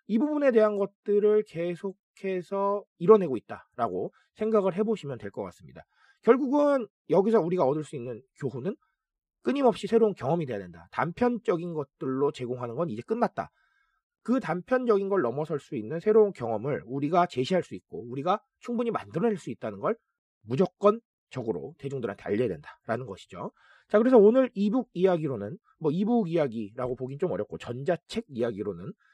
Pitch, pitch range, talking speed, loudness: 190 Hz, 140-225 Hz, 370 characters per minute, -28 LUFS